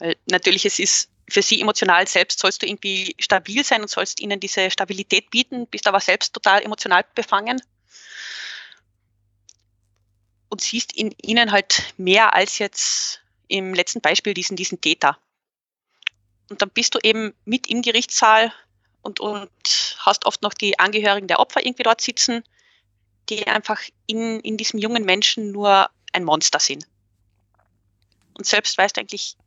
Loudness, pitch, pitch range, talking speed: -19 LUFS, 200 Hz, 145-220 Hz, 150 wpm